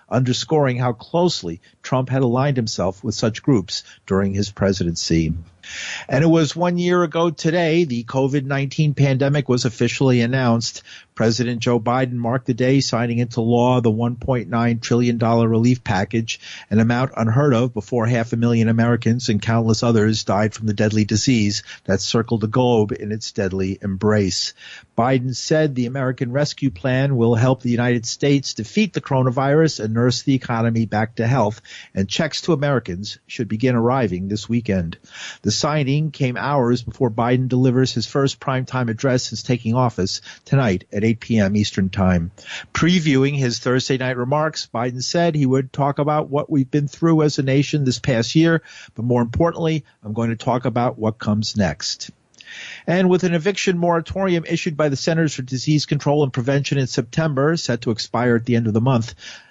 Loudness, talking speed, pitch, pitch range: -19 LUFS, 175 wpm, 125 Hz, 115-140 Hz